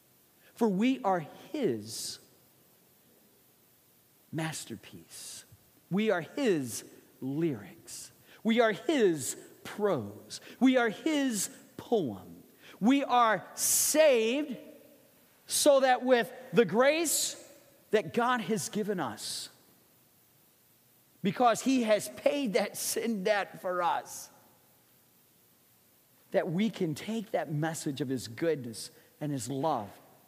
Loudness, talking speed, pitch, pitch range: -30 LUFS, 100 wpm, 215 Hz, 160-255 Hz